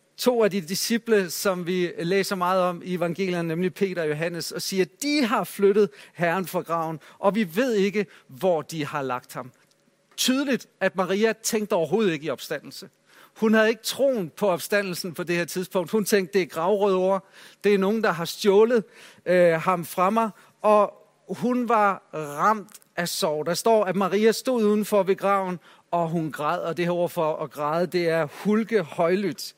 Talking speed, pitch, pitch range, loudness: 190 wpm, 190 Hz, 170-210 Hz, -24 LUFS